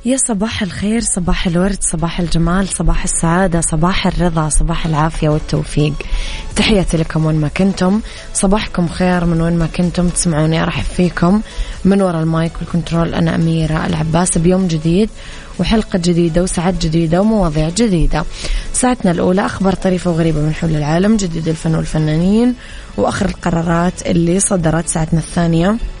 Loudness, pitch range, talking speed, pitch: -15 LUFS, 165-190 Hz, 140 wpm, 175 Hz